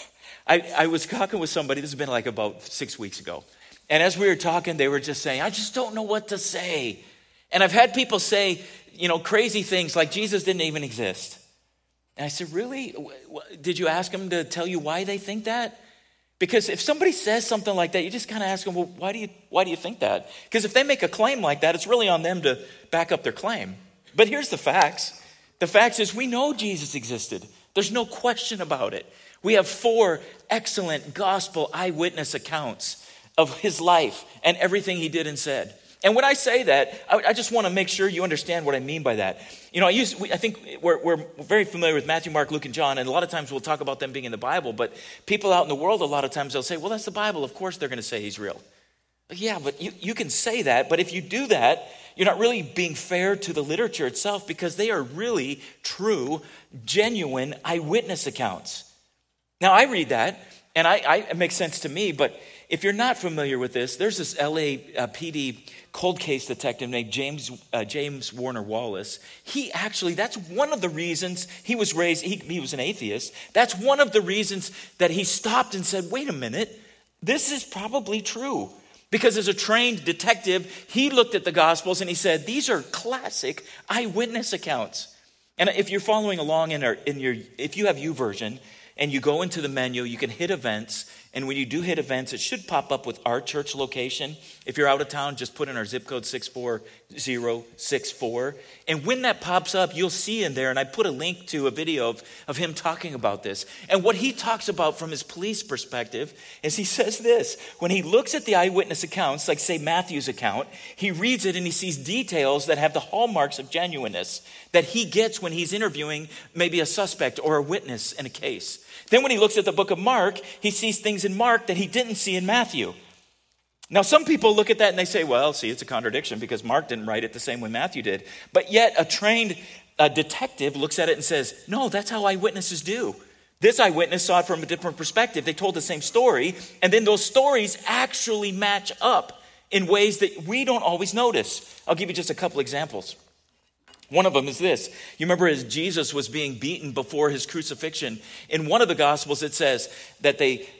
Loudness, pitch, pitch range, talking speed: -24 LUFS, 180 Hz, 150-215 Hz, 220 wpm